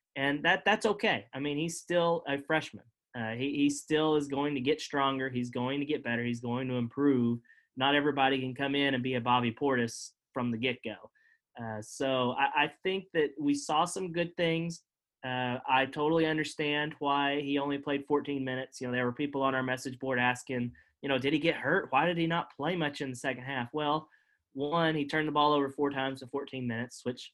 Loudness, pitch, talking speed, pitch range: -31 LUFS, 140 Hz, 225 wpm, 130-155 Hz